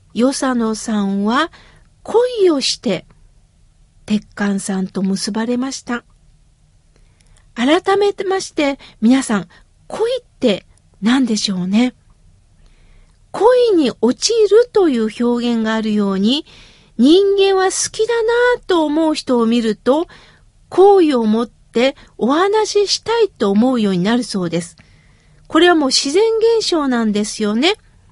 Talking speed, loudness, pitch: 235 characters per minute, -16 LUFS, 260 Hz